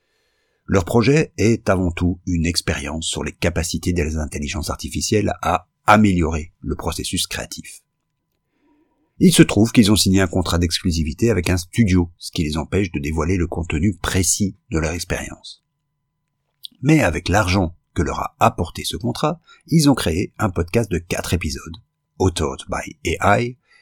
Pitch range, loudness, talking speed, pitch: 85-115 Hz, -19 LUFS, 155 wpm, 95 Hz